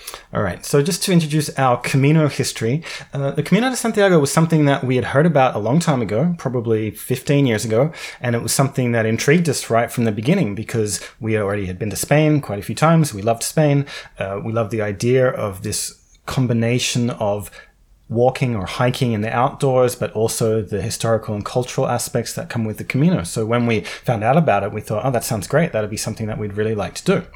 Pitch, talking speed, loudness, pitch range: 120 Hz, 225 wpm, -19 LUFS, 110-145 Hz